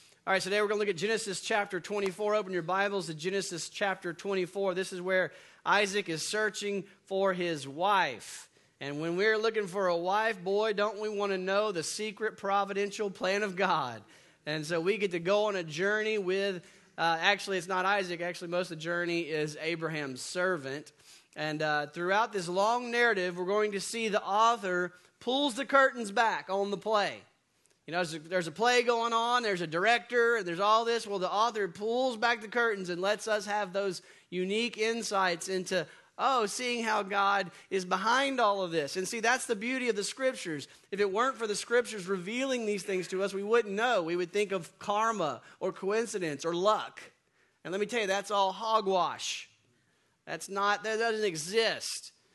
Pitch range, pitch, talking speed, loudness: 180-215 Hz, 200 Hz, 195 wpm, -30 LUFS